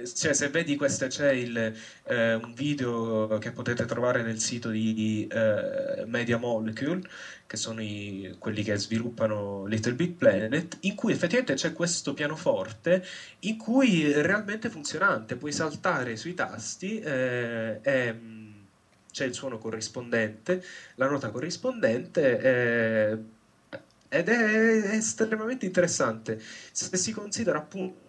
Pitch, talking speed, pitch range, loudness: 130 Hz, 130 wpm, 110-180 Hz, -28 LUFS